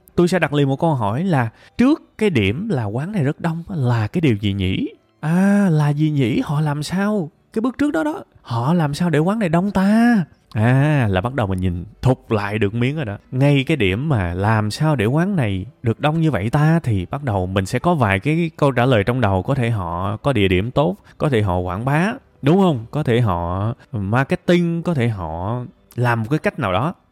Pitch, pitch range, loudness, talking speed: 140 Hz, 110-165 Hz, -19 LUFS, 235 wpm